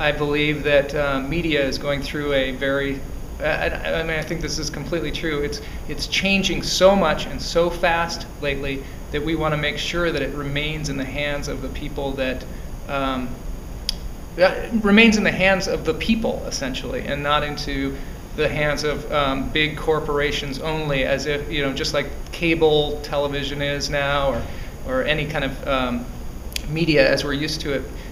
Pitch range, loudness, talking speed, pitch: 140-155 Hz, -22 LUFS, 185 wpm, 145 Hz